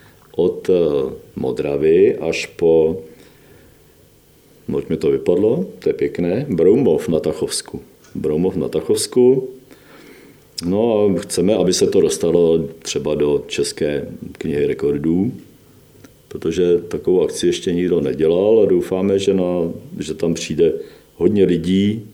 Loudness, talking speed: -18 LUFS, 120 wpm